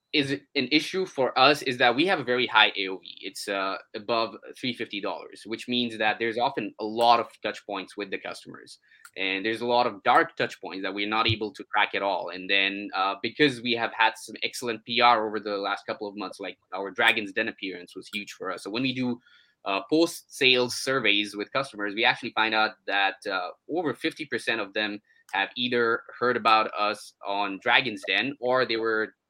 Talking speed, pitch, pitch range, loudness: 205 wpm, 115 Hz, 105-125 Hz, -26 LUFS